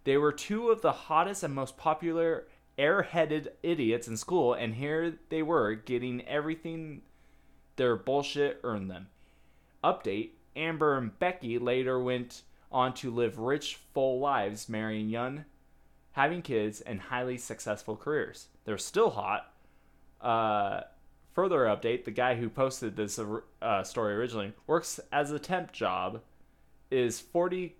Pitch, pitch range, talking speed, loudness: 125 Hz, 110-155 Hz, 140 wpm, -31 LUFS